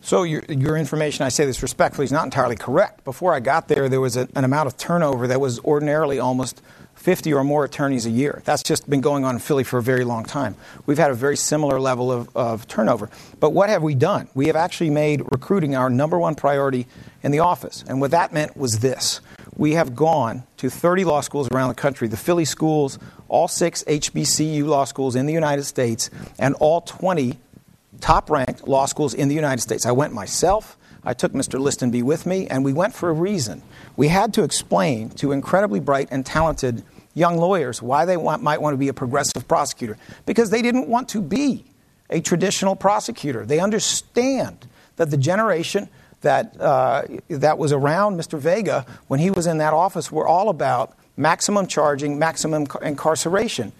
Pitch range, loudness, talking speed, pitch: 130-165 Hz, -20 LUFS, 200 wpm, 150 Hz